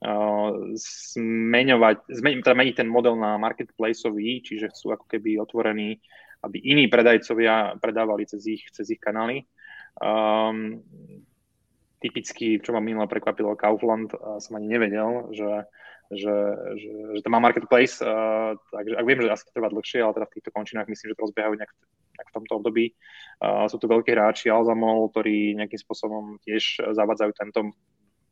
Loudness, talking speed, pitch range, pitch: -24 LUFS, 155 wpm, 105-115 Hz, 110 Hz